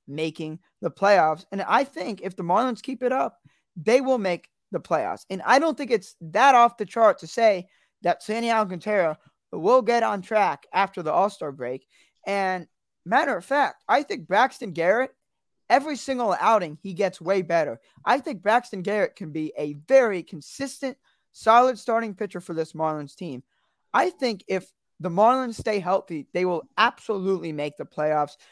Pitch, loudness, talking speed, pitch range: 200 Hz, -24 LUFS, 175 wpm, 170-240 Hz